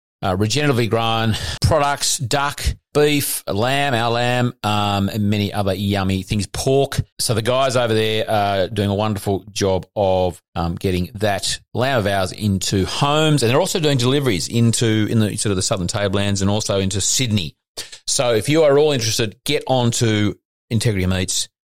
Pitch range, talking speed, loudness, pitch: 100-125 Hz, 175 wpm, -19 LUFS, 110 Hz